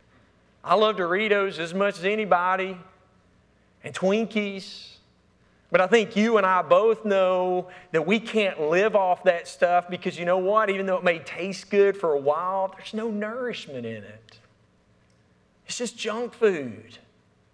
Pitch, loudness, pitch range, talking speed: 185 Hz, -24 LUFS, 175-210 Hz, 155 wpm